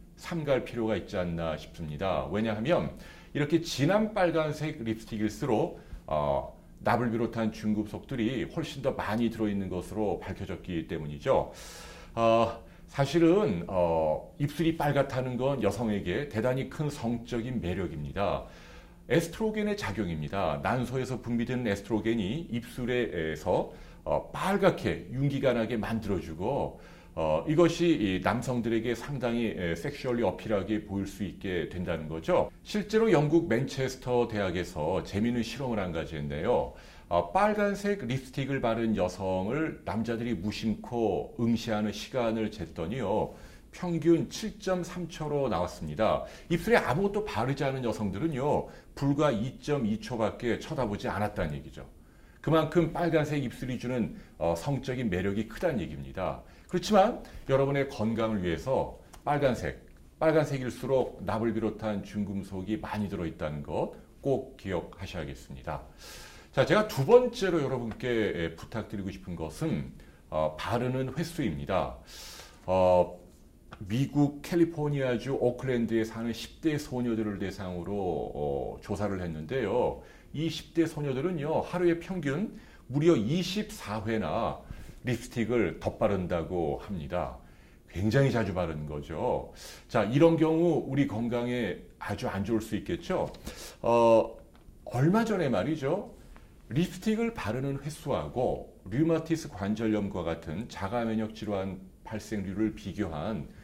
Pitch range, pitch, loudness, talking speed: 100-145 Hz, 115 Hz, -30 LUFS, 290 characters per minute